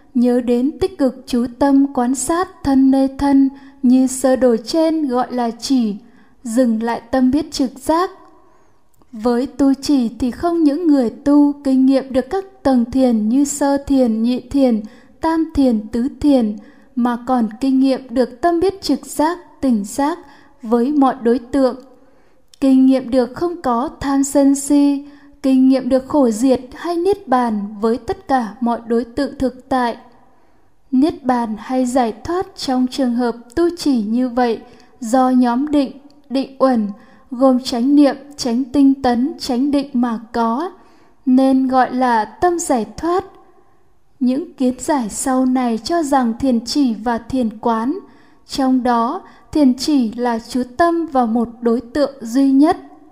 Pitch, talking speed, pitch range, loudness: 265 Hz, 165 wpm, 245-285 Hz, -17 LUFS